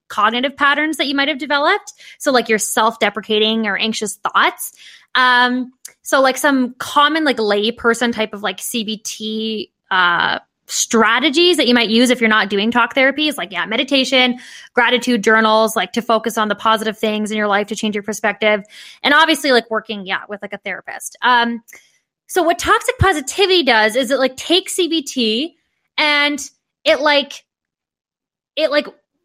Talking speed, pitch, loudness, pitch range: 165 wpm, 245 Hz, -15 LUFS, 220-290 Hz